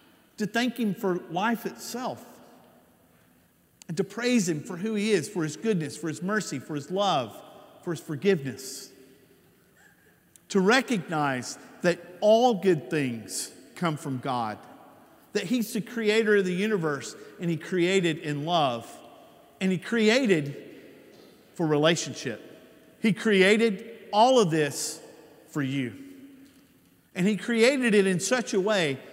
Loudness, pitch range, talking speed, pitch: -26 LUFS, 150-215 Hz, 140 wpm, 185 Hz